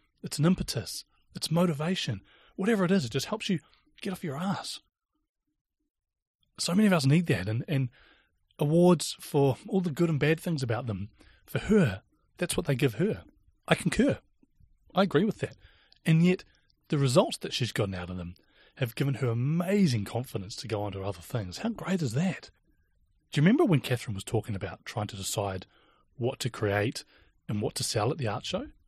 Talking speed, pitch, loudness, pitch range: 195 wpm, 140 Hz, -29 LUFS, 110-180 Hz